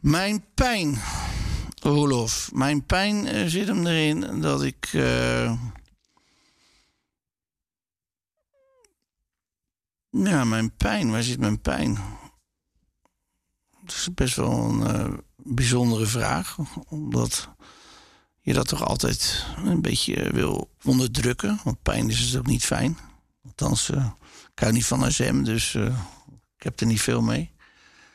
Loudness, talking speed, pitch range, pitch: -24 LUFS, 120 wpm, 105-145 Hz, 125 Hz